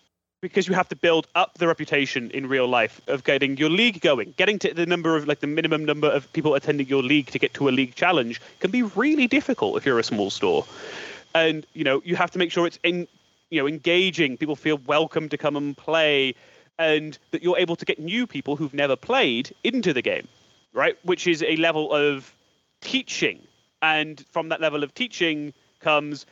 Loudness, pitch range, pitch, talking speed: -23 LUFS, 145-180 Hz, 160 Hz, 210 wpm